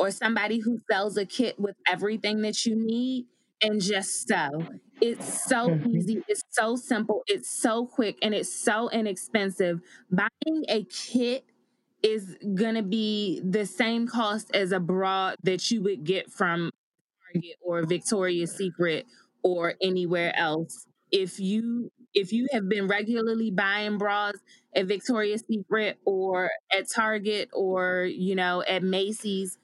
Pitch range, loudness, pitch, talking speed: 190-225 Hz, -27 LUFS, 205 Hz, 145 wpm